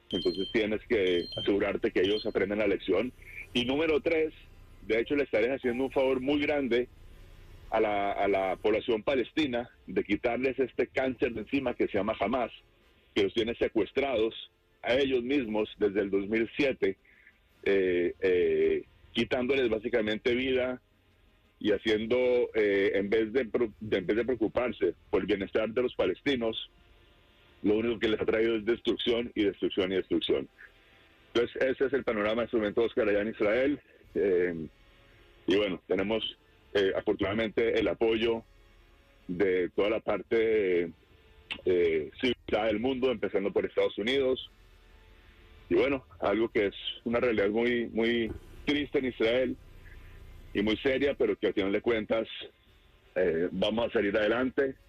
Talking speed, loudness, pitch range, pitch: 155 wpm, -29 LUFS, 100-145 Hz, 120 Hz